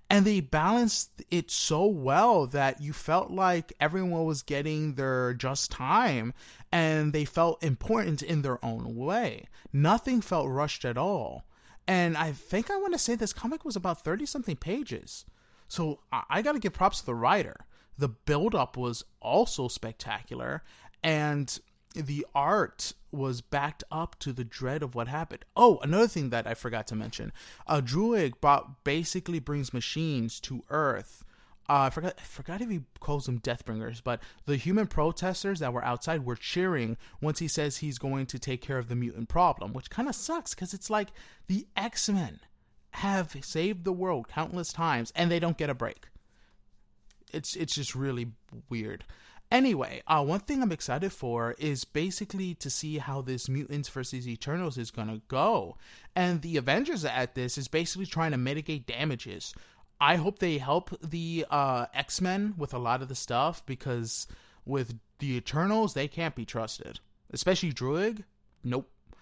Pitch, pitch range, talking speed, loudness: 150 Hz, 125-180 Hz, 170 wpm, -30 LUFS